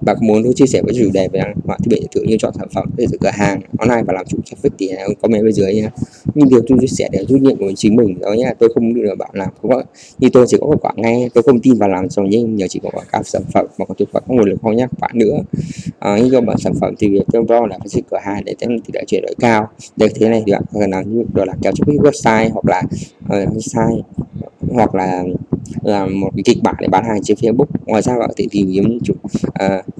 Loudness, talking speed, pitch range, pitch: -15 LUFS, 275 wpm, 100-120 Hz, 110 Hz